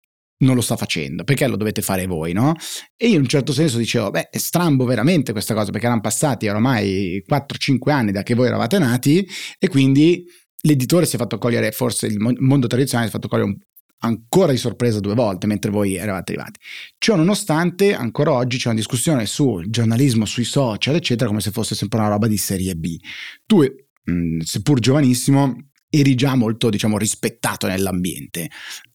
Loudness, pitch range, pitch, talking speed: -19 LUFS, 105-140 Hz, 120 Hz, 185 wpm